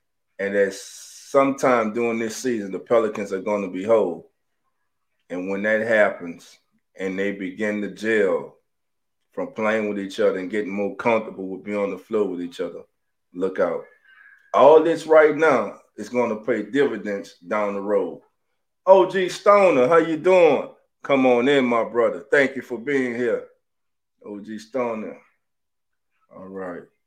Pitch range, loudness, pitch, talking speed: 100-155 Hz, -21 LUFS, 115 Hz, 155 wpm